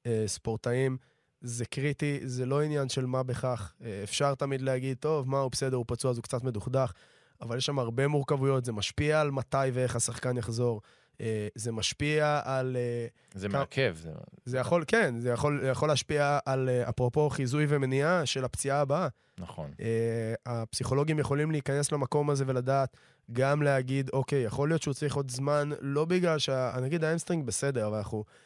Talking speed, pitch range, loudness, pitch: 160 wpm, 120-145 Hz, -30 LUFS, 135 Hz